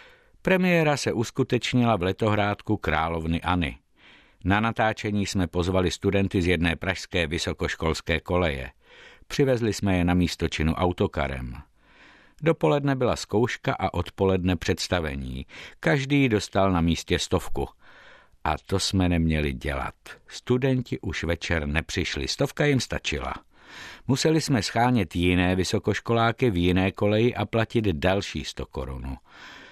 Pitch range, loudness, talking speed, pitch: 85-115 Hz, -25 LUFS, 120 wpm, 95 Hz